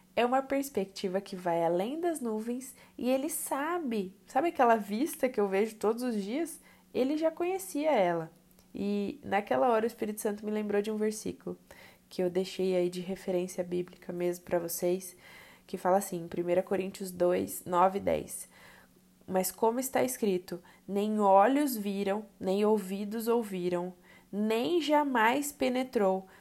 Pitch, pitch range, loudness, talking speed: 205 Hz, 185-245 Hz, -31 LUFS, 150 wpm